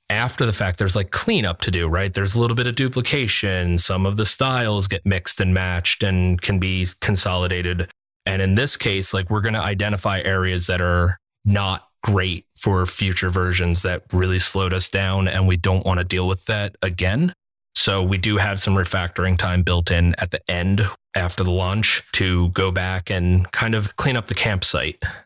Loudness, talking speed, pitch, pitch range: -20 LUFS, 195 wpm, 95 Hz, 90-105 Hz